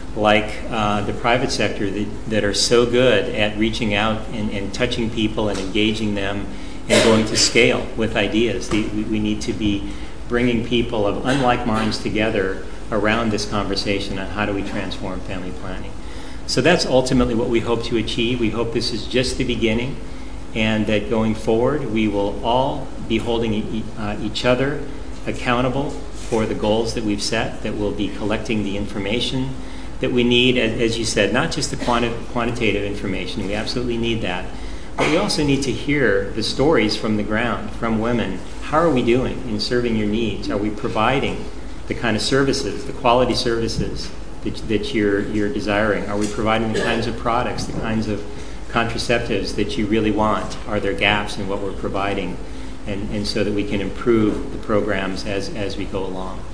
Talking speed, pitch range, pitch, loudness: 185 wpm, 105-120 Hz, 110 Hz, -20 LUFS